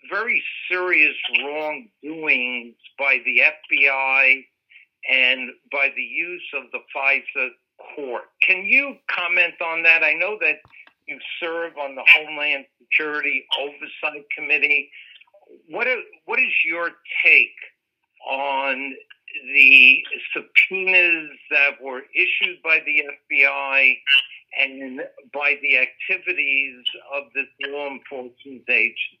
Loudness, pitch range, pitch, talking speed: -18 LUFS, 135-170 Hz, 145 Hz, 110 wpm